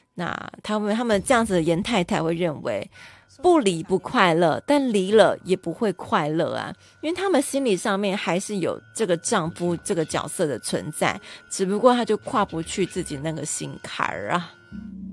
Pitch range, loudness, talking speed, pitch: 175-225 Hz, -23 LUFS, 265 characters per minute, 200 Hz